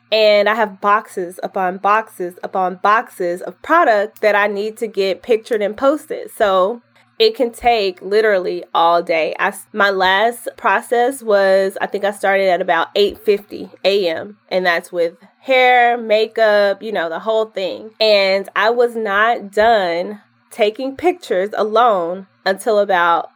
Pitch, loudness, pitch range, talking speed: 205 Hz, -16 LUFS, 190-225 Hz, 150 wpm